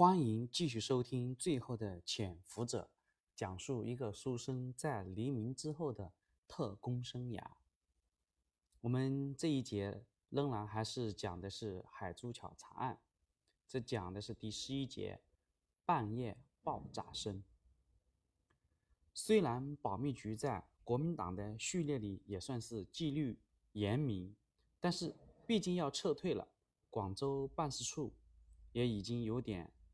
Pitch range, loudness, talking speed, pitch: 95-135 Hz, -41 LUFS, 190 characters per minute, 110 Hz